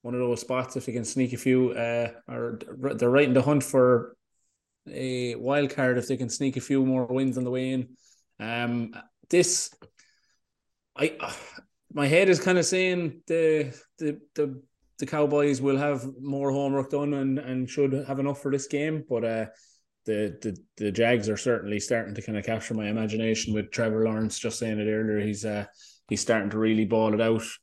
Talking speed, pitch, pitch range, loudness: 200 wpm, 125 Hz, 110-140 Hz, -27 LUFS